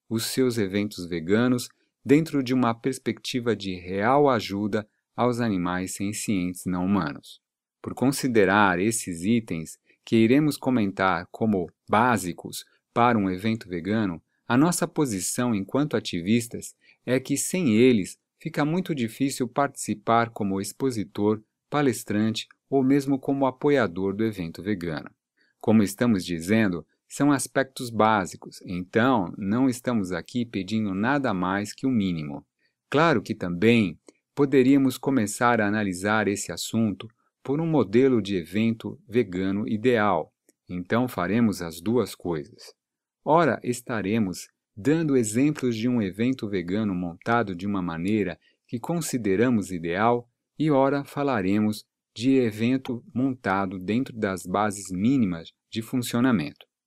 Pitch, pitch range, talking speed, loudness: 110 Hz, 100-130 Hz, 125 wpm, -25 LUFS